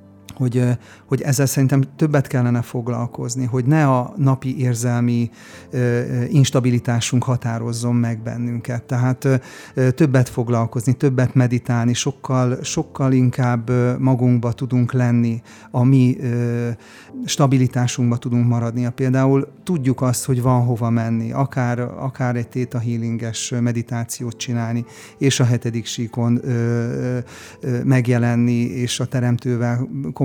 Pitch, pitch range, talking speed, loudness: 125 Hz, 120-130 Hz, 120 wpm, -19 LUFS